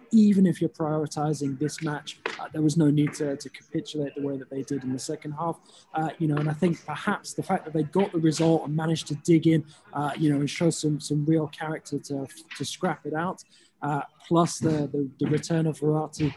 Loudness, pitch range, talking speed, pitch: -27 LUFS, 145-165 Hz, 235 wpm, 155 Hz